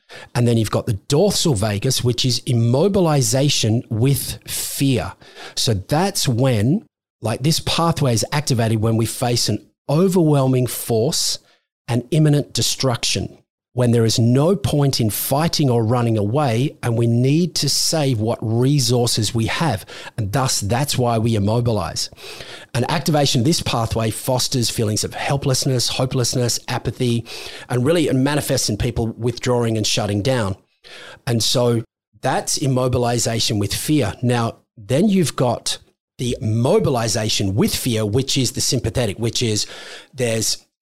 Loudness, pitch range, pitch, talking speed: -19 LUFS, 115-135 Hz, 120 Hz, 140 wpm